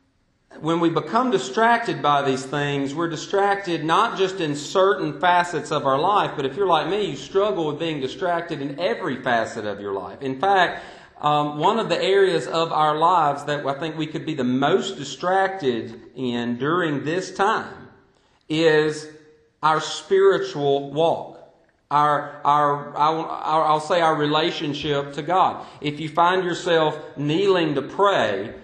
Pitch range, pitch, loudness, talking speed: 145-170 Hz, 155 Hz, -21 LUFS, 155 wpm